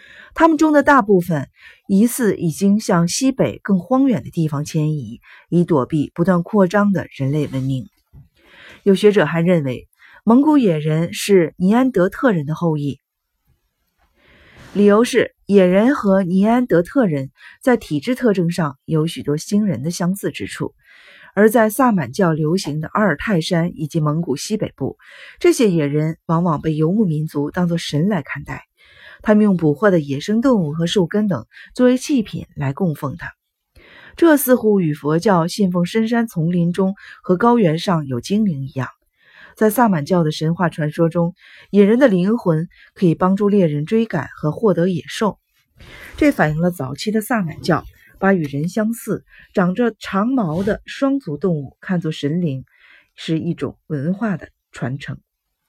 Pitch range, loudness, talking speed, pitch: 155-210 Hz, -18 LUFS, 240 characters per minute, 180 Hz